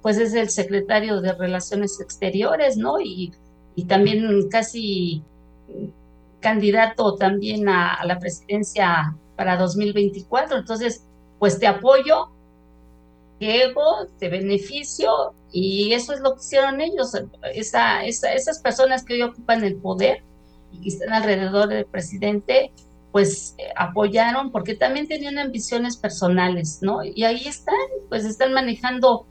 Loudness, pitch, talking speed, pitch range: -21 LUFS, 205 Hz, 130 wpm, 180-240 Hz